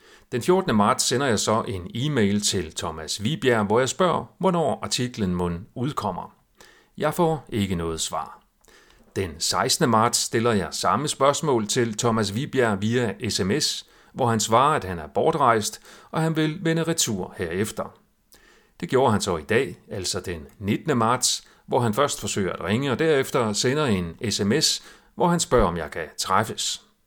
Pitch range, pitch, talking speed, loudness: 100-150 Hz, 115 Hz, 170 wpm, -23 LUFS